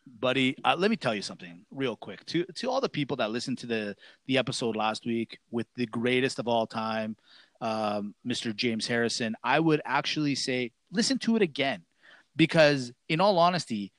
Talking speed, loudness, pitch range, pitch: 190 wpm, -28 LUFS, 115-155 Hz, 125 Hz